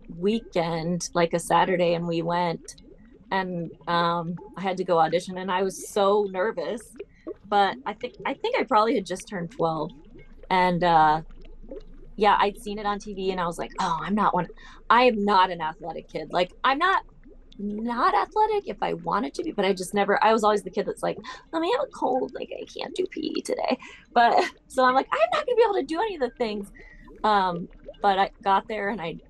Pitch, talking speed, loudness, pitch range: 200 Hz, 215 wpm, -25 LUFS, 175-245 Hz